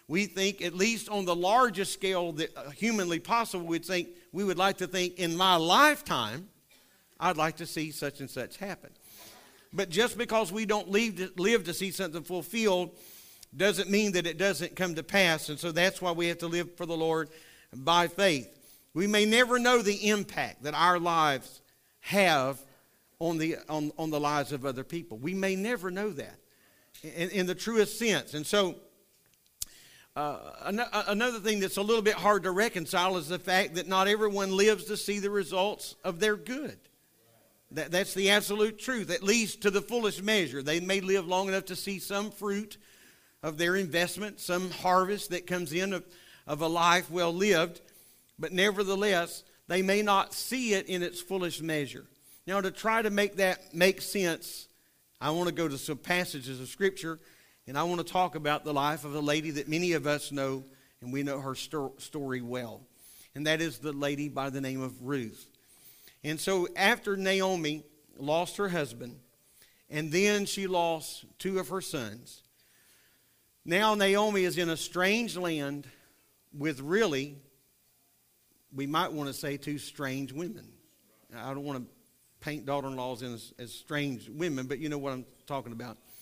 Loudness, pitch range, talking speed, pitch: -30 LUFS, 150-195 Hz, 180 wpm, 175 Hz